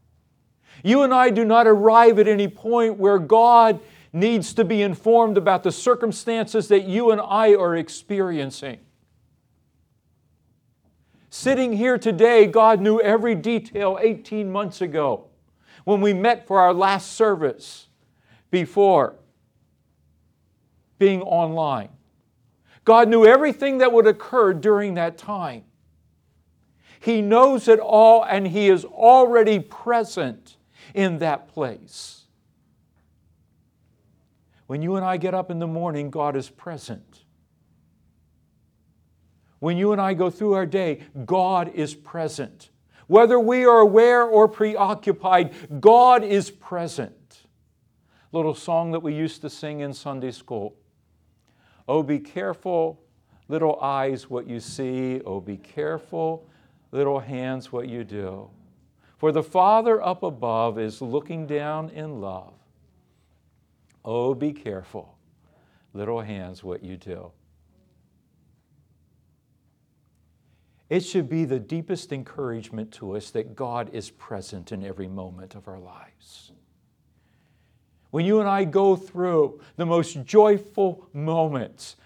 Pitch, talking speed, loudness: 160 Hz, 125 wpm, -20 LUFS